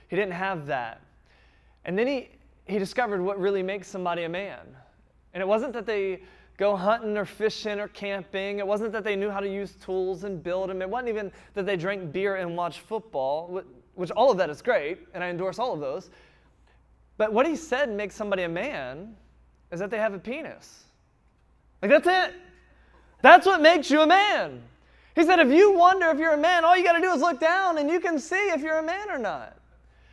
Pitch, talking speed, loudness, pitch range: 205 Hz, 215 wpm, -24 LUFS, 190-305 Hz